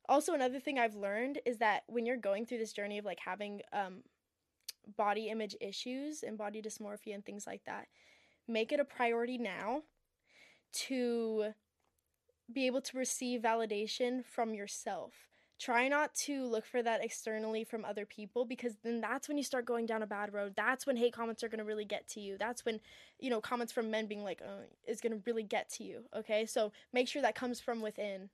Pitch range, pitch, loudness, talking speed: 215-250 Hz, 230 Hz, -38 LUFS, 200 wpm